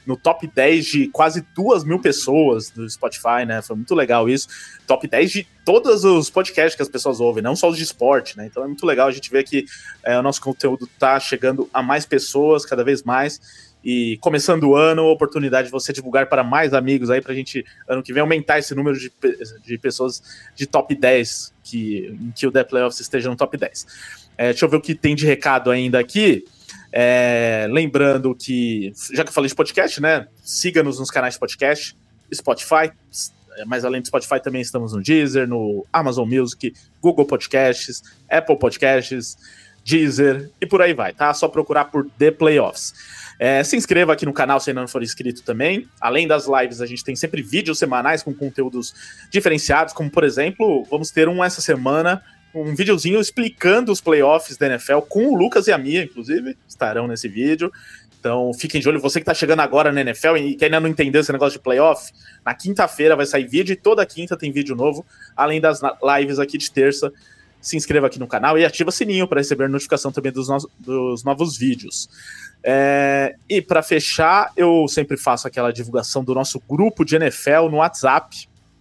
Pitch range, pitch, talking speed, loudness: 130-160 Hz, 140 Hz, 200 wpm, -18 LUFS